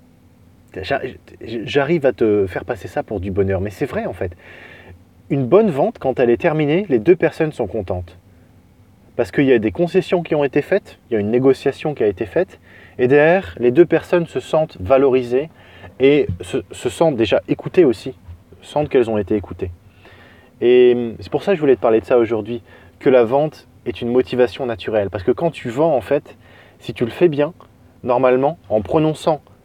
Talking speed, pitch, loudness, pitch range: 200 wpm, 120 Hz, -18 LUFS, 100-145 Hz